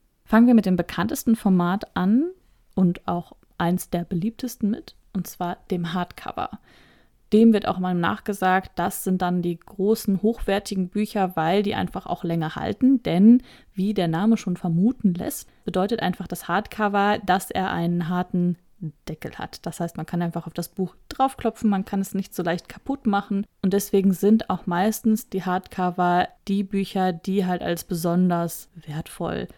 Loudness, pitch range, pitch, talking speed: -23 LUFS, 175-210 Hz, 190 Hz, 170 wpm